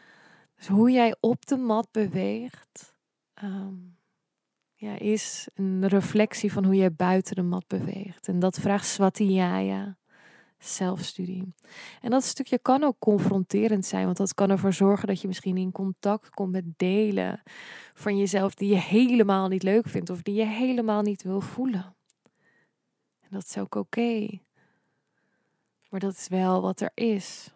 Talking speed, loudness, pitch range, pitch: 155 wpm, -26 LUFS, 185-215 Hz, 195 Hz